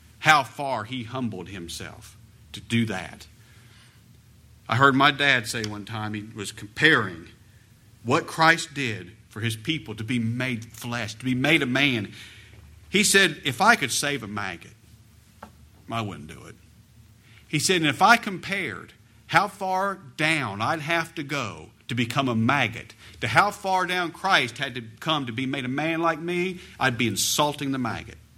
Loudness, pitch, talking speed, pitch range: -24 LUFS, 120 Hz, 175 wpm, 110-150 Hz